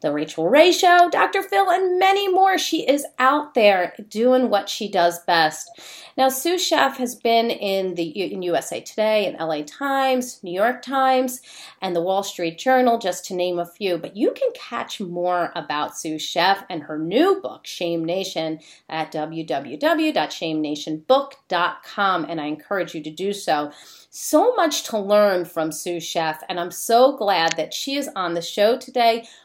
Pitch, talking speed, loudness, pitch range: 200 Hz, 175 wpm, -21 LUFS, 170-265 Hz